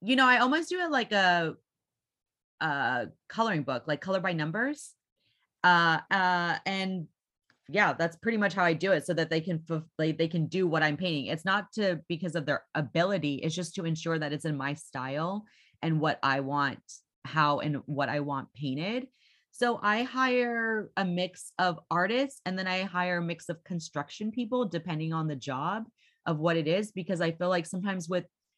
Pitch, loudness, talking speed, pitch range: 175 Hz, -29 LUFS, 195 wpm, 160-195 Hz